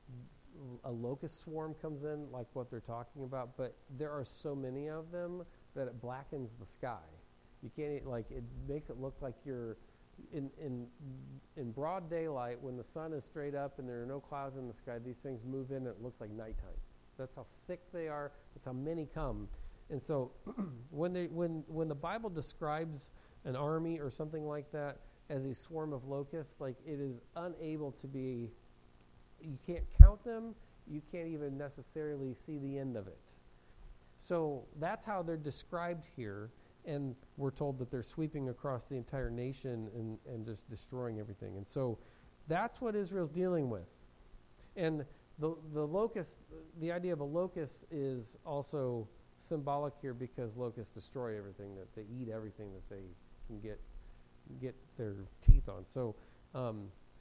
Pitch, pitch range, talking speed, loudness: 135 Hz, 115-155 Hz, 180 wpm, -40 LUFS